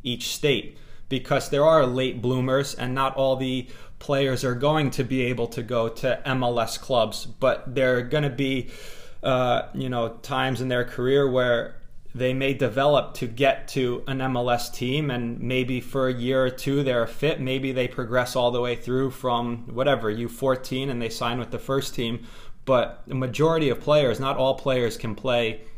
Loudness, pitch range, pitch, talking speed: -24 LUFS, 120-135 Hz, 130 Hz, 190 wpm